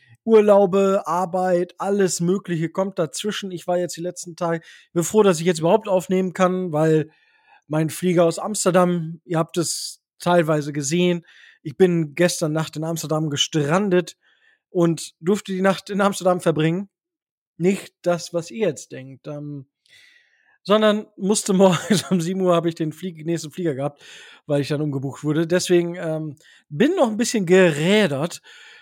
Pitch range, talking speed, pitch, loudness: 160-195 Hz, 160 wpm, 175 Hz, -21 LUFS